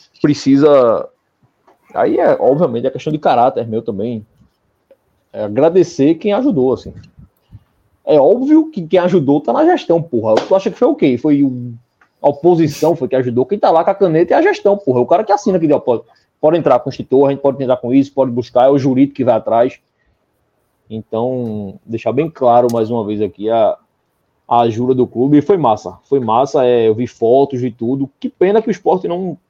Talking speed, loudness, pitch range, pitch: 210 wpm, -14 LUFS, 120-170 Hz, 135 Hz